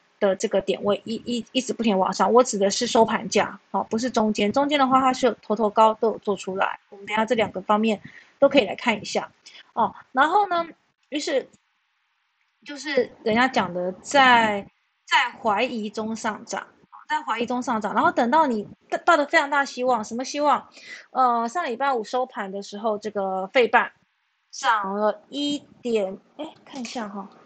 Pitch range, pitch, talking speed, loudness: 210-265 Hz, 230 Hz, 270 characters per minute, -23 LUFS